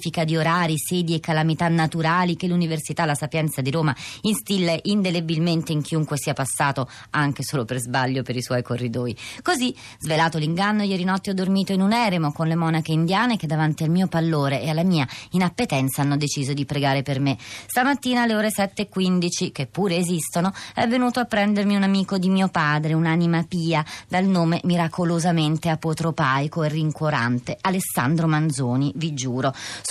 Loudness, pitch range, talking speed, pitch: -22 LUFS, 145-185 Hz, 170 wpm, 160 Hz